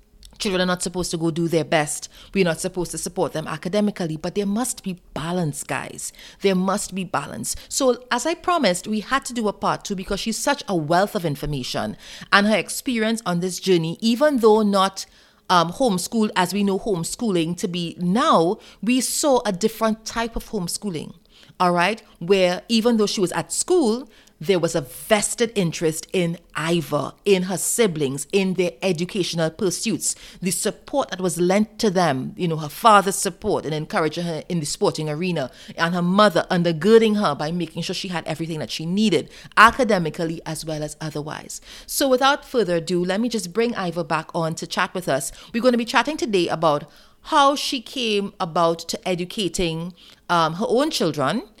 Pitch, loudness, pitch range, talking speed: 185 Hz, -21 LUFS, 170-220 Hz, 185 wpm